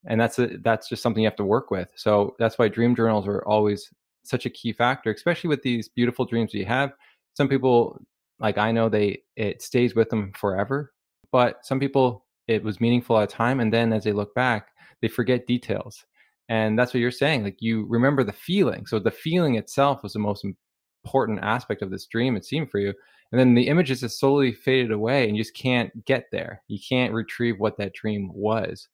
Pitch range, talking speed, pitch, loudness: 105-125 Hz, 220 wpm, 115 Hz, -24 LUFS